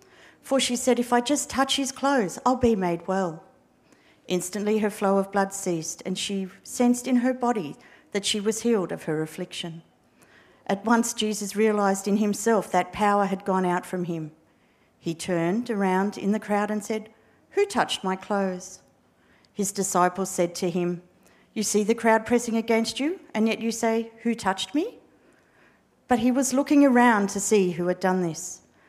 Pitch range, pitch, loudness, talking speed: 185-235 Hz, 205 Hz, -25 LUFS, 180 wpm